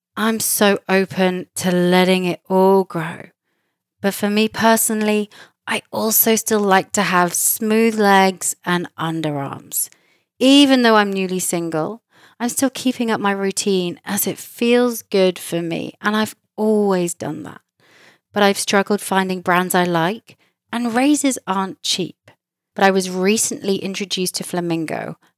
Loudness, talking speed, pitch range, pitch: -18 LUFS, 145 wpm, 180-215 Hz, 195 Hz